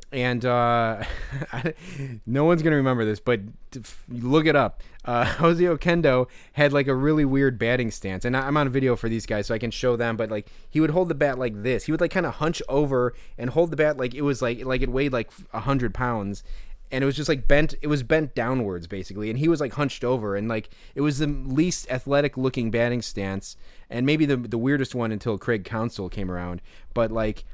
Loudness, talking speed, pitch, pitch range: -24 LUFS, 225 wpm, 125 Hz, 115-145 Hz